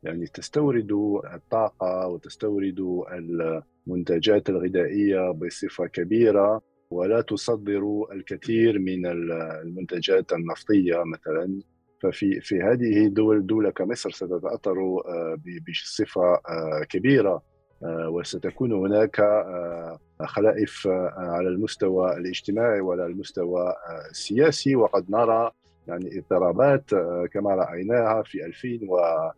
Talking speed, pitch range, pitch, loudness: 85 wpm, 85-105 Hz, 90 Hz, -25 LUFS